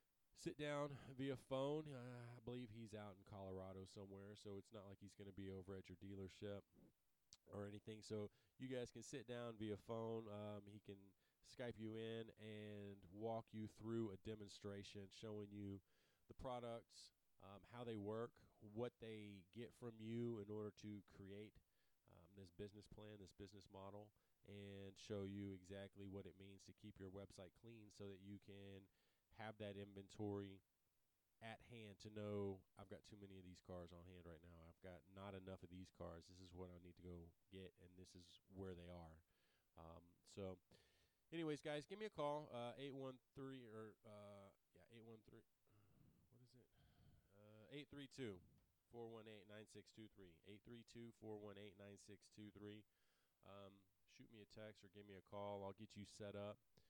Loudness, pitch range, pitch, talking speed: -56 LUFS, 95-115 Hz, 105 Hz, 180 wpm